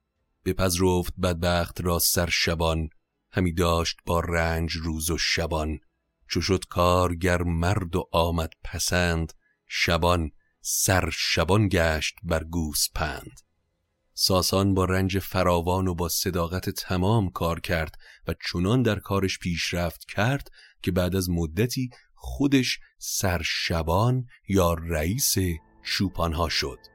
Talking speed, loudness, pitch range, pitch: 115 wpm, -25 LUFS, 85-95 Hz, 90 Hz